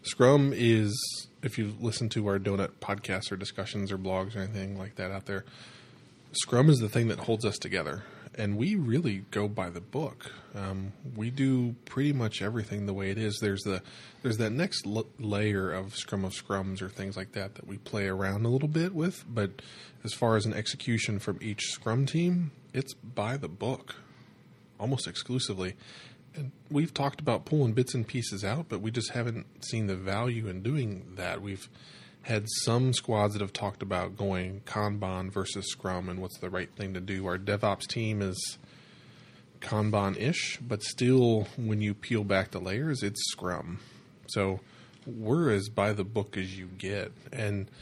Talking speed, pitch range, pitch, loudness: 185 wpm, 100-125 Hz, 105 Hz, -31 LUFS